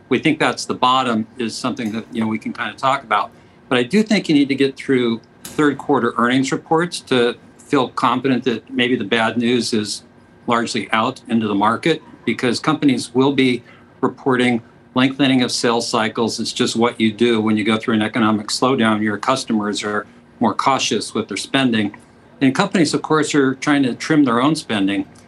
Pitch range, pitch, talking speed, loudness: 115-135 Hz, 120 Hz, 195 wpm, -18 LUFS